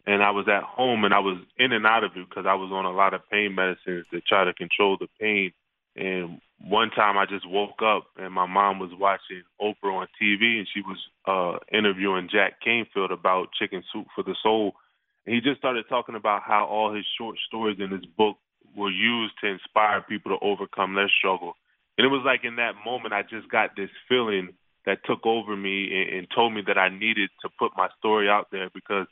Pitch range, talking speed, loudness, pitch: 95-110 Hz, 225 wpm, -24 LUFS, 100 Hz